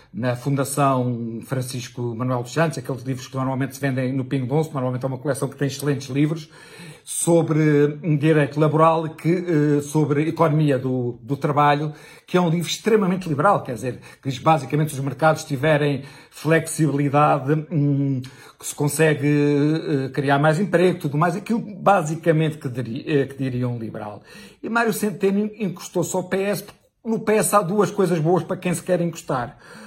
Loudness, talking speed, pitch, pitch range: -21 LUFS, 165 wpm, 150 Hz, 135-170 Hz